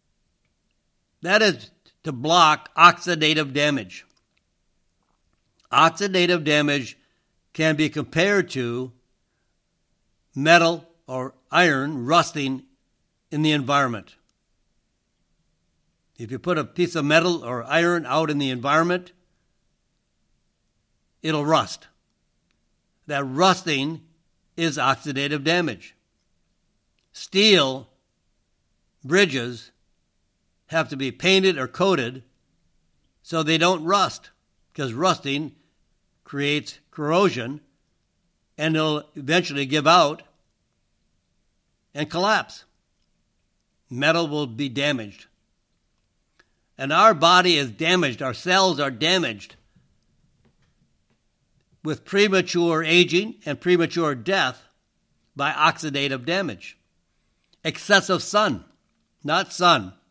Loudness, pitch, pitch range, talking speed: -21 LUFS, 150 Hz, 130-175 Hz, 90 wpm